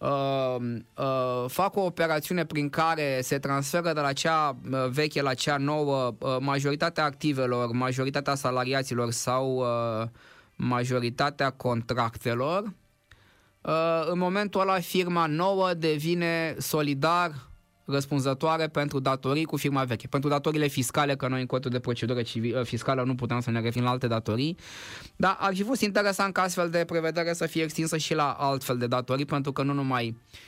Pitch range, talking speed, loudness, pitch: 125-160 Hz, 155 wpm, -27 LUFS, 140 Hz